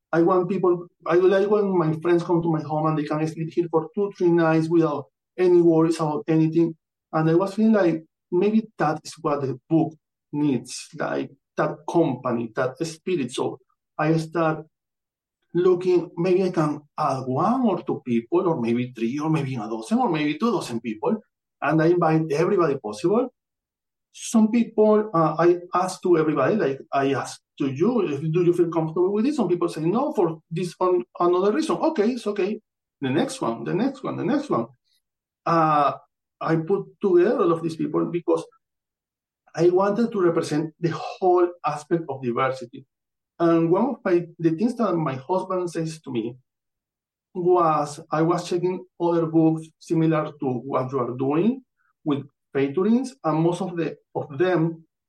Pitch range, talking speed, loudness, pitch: 150-180 Hz, 175 wpm, -23 LUFS, 165 Hz